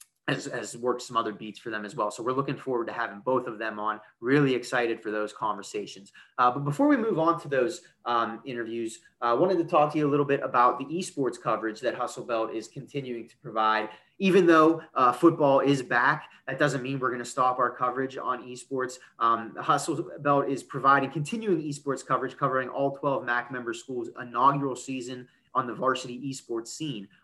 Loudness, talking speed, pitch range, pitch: -27 LUFS, 205 wpm, 120-145 Hz, 130 Hz